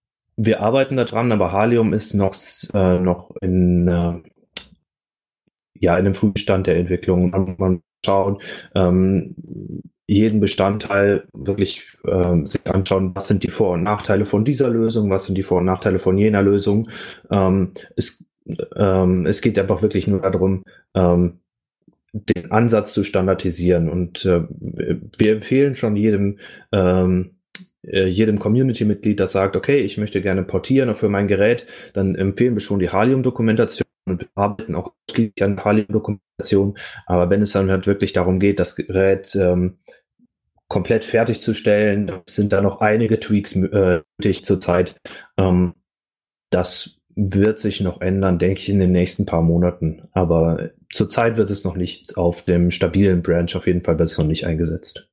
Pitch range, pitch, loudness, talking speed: 90-105 Hz, 95 Hz, -19 LUFS, 155 wpm